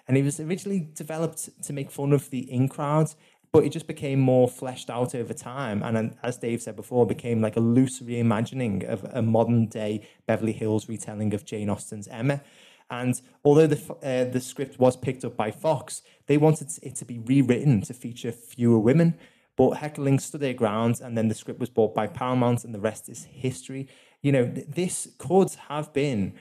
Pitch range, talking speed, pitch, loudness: 115-145 Hz, 200 wpm, 130 Hz, -26 LUFS